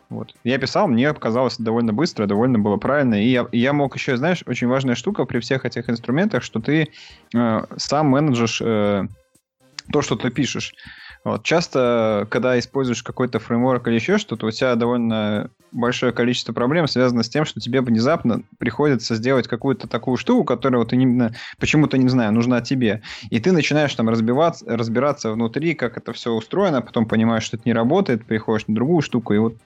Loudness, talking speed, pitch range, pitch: -20 LUFS, 185 wpm, 115-135 Hz, 120 Hz